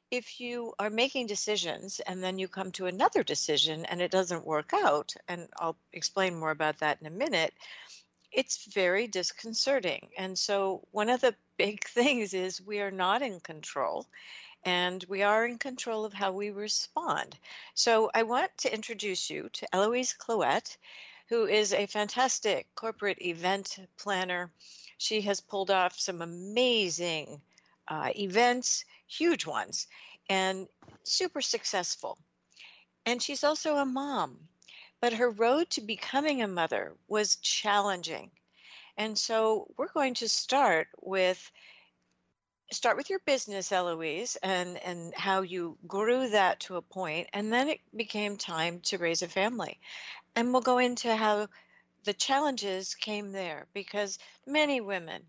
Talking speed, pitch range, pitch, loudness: 150 wpm, 185-240 Hz, 205 Hz, -30 LUFS